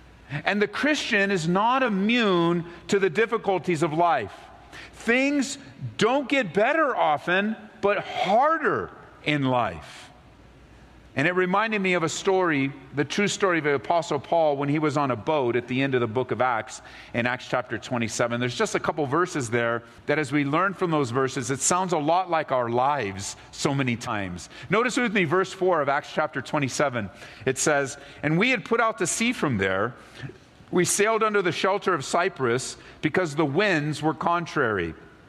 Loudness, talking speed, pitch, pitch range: -24 LUFS, 180 wpm, 155 Hz, 130-195 Hz